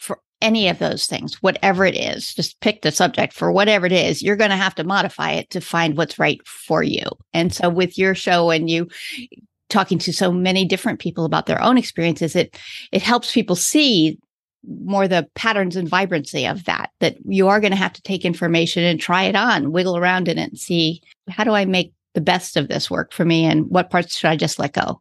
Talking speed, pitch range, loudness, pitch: 230 wpm, 170-200 Hz, -18 LUFS, 185 Hz